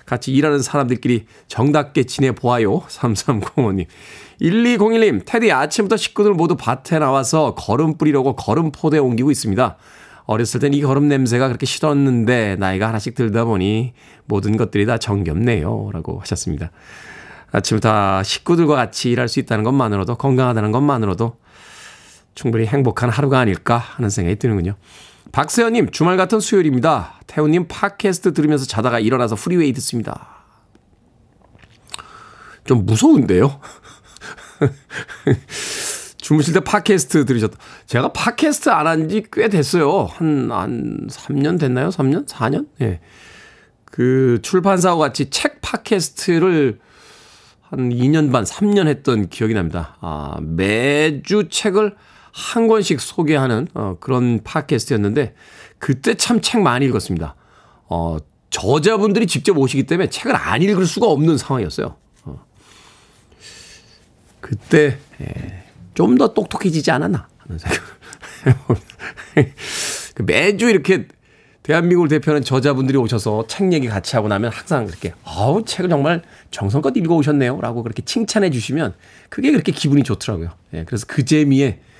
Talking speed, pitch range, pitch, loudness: 305 characters per minute, 110-160 Hz, 130 Hz, -17 LUFS